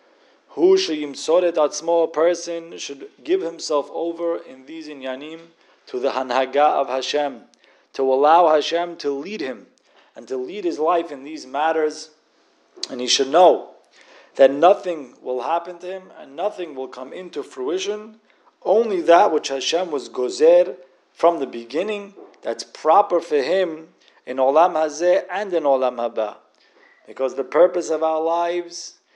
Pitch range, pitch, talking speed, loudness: 140-185 Hz, 165 Hz, 150 wpm, -20 LUFS